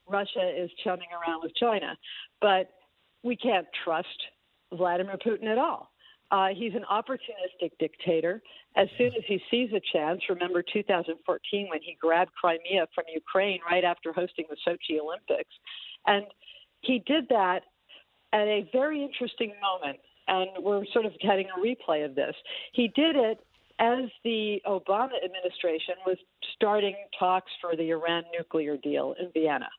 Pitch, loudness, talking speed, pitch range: 190 Hz, -29 LUFS, 150 wpm, 175-225 Hz